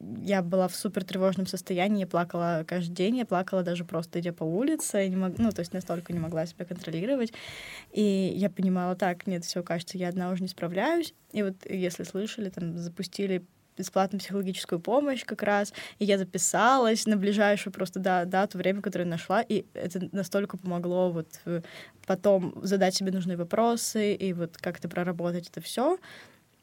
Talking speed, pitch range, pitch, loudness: 175 wpm, 180-200 Hz, 190 Hz, -29 LUFS